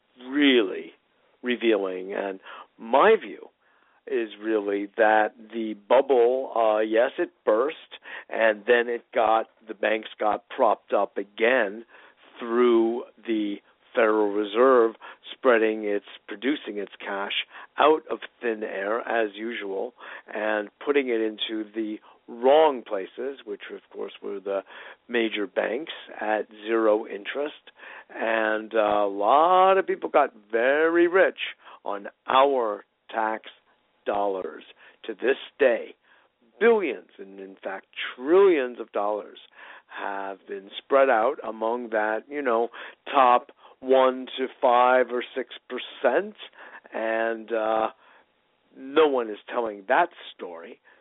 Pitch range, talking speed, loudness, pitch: 110-135 Hz, 120 wpm, -24 LUFS, 115 Hz